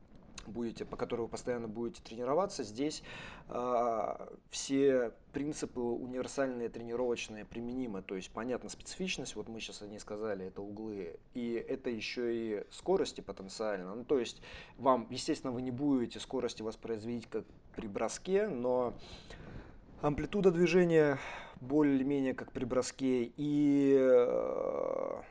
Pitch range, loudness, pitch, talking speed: 115-145 Hz, -35 LUFS, 125 Hz, 125 wpm